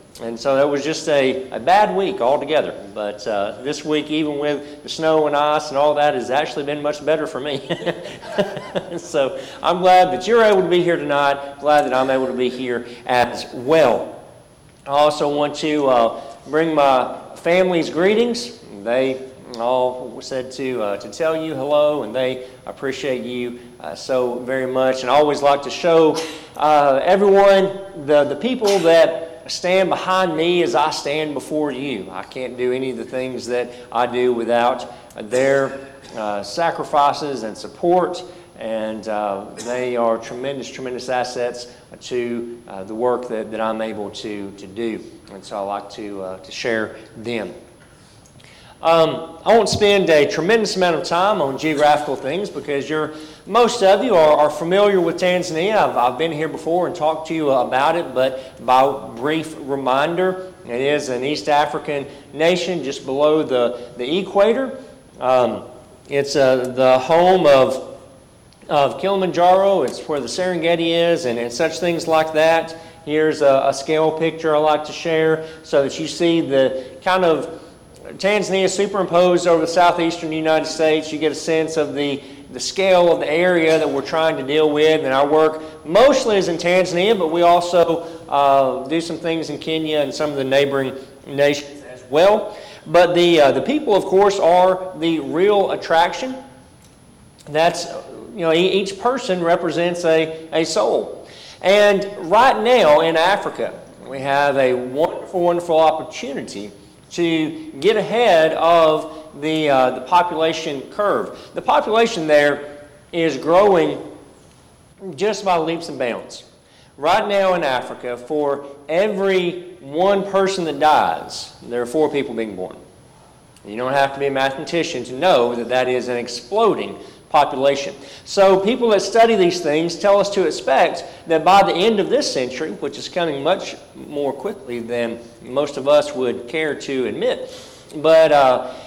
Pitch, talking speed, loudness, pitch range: 150 Hz, 165 wpm, -18 LUFS, 130-175 Hz